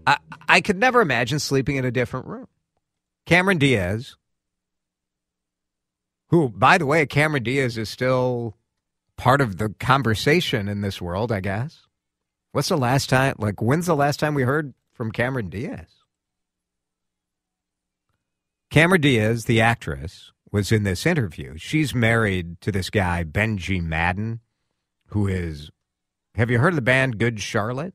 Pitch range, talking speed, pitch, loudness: 90-135 Hz, 145 wpm, 115 Hz, -21 LUFS